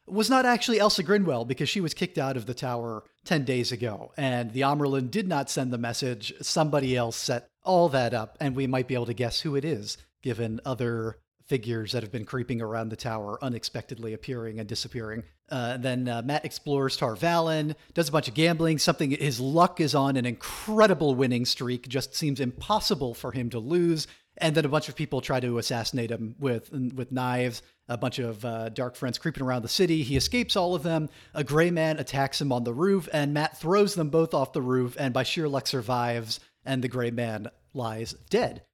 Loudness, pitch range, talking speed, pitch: -27 LUFS, 120-155 Hz, 210 wpm, 135 Hz